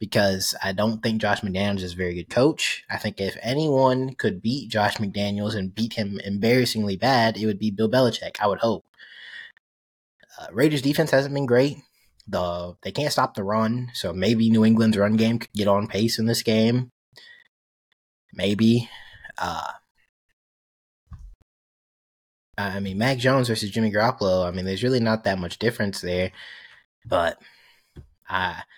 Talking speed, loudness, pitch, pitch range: 160 wpm, -23 LUFS, 110 Hz, 95-115 Hz